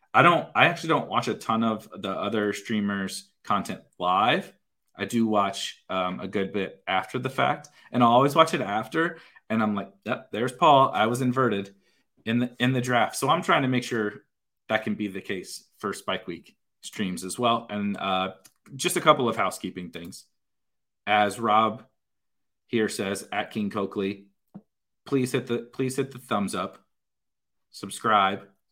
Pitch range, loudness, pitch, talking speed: 100-125 Hz, -25 LUFS, 110 Hz, 180 wpm